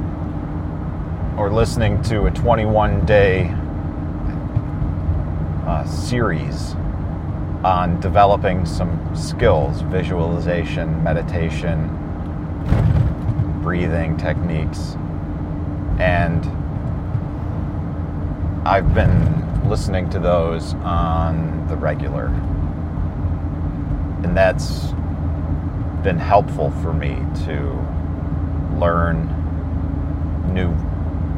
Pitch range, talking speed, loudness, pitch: 80-85 Hz, 65 wpm, -20 LUFS, 80 Hz